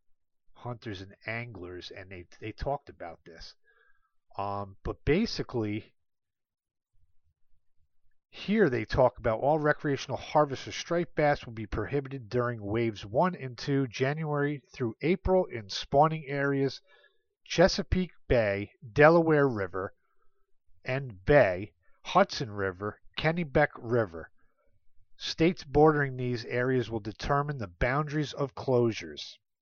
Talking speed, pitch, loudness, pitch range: 115 wpm, 130 Hz, -29 LUFS, 110-150 Hz